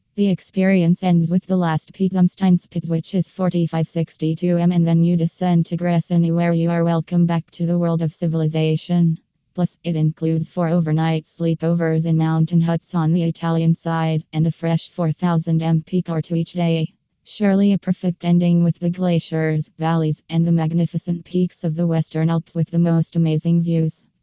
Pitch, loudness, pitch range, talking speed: 170 Hz, -20 LUFS, 160-175 Hz, 170 wpm